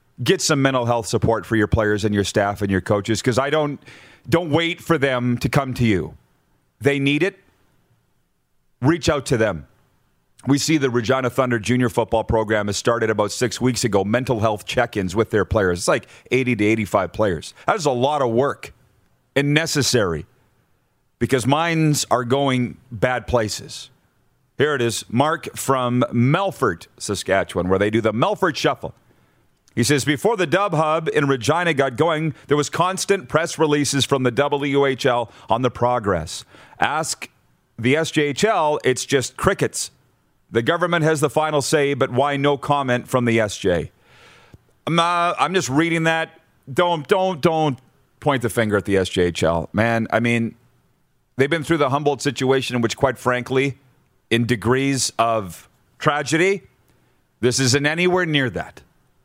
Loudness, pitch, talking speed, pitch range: -20 LUFS, 130 Hz, 165 wpm, 115-150 Hz